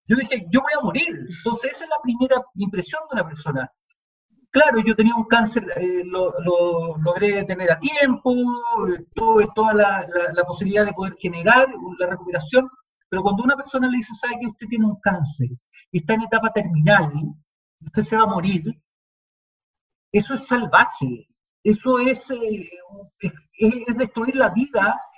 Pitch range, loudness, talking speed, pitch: 180-250 Hz, -20 LUFS, 165 wpm, 215 Hz